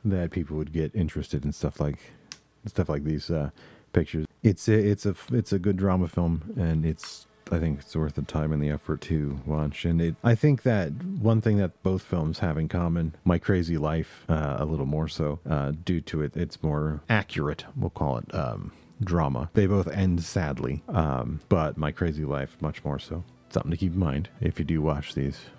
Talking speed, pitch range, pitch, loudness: 210 wpm, 75-95 Hz, 80 Hz, -28 LUFS